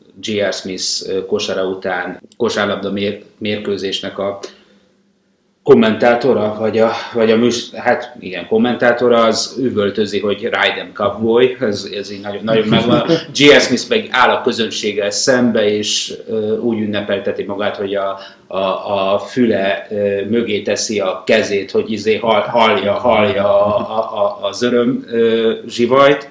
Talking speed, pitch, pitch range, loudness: 130 wpm, 110 Hz, 100-120 Hz, -15 LUFS